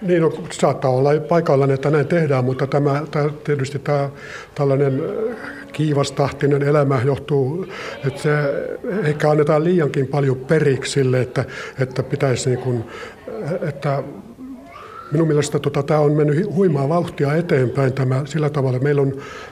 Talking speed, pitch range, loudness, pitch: 135 wpm, 135-155 Hz, -19 LUFS, 145 Hz